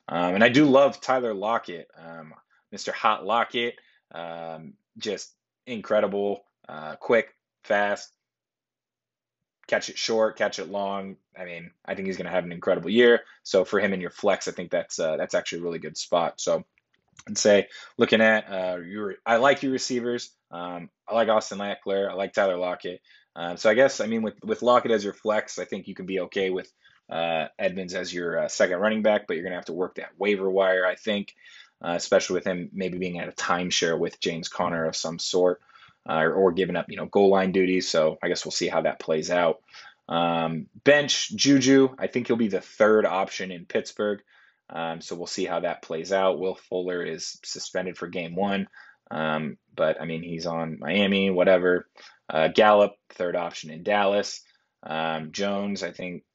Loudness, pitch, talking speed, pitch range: -25 LUFS, 95 Hz, 200 wpm, 85-110 Hz